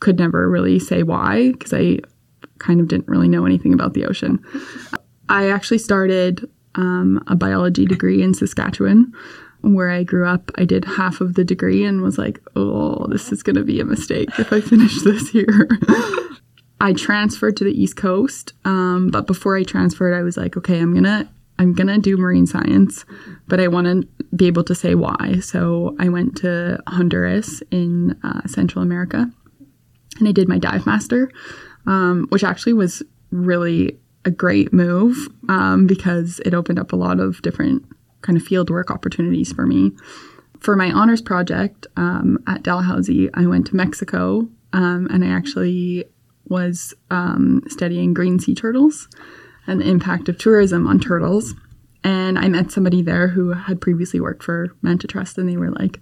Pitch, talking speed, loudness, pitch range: 180 Hz, 180 wpm, -17 LUFS, 120-190 Hz